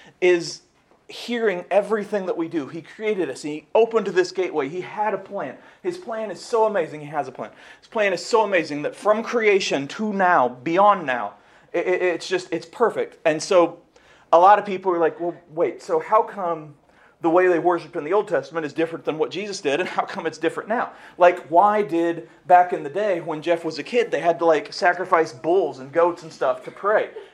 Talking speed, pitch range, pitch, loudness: 215 wpm, 165-210 Hz, 180 Hz, -22 LUFS